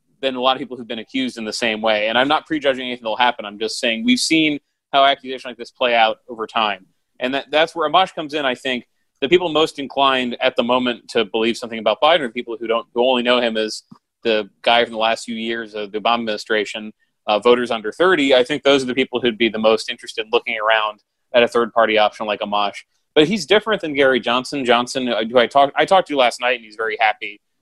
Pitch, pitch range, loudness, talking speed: 125 Hz, 115-140 Hz, -18 LUFS, 255 wpm